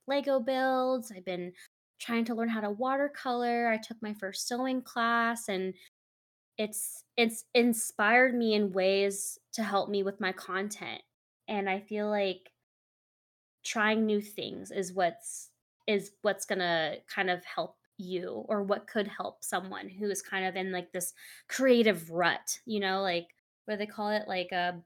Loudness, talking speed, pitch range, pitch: -31 LUFS, 165 wpm, 185-230 Hz, 205 Hz